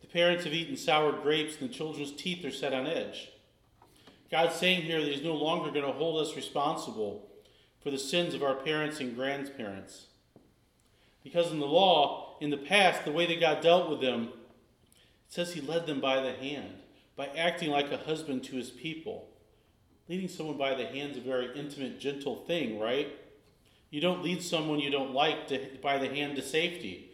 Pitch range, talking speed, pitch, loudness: 135-165 Hz, 195 wpm, 150 Hz, -31 LUFS